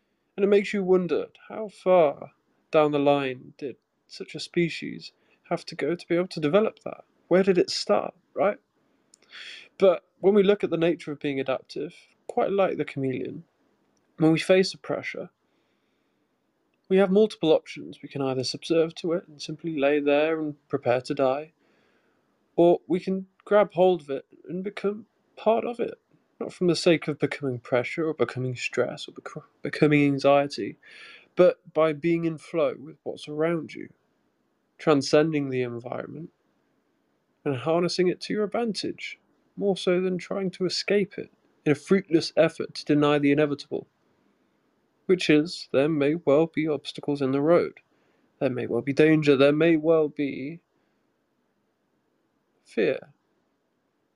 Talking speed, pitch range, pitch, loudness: 160 wpm, 145-185 Hz, 160 Hz, -25 LUFS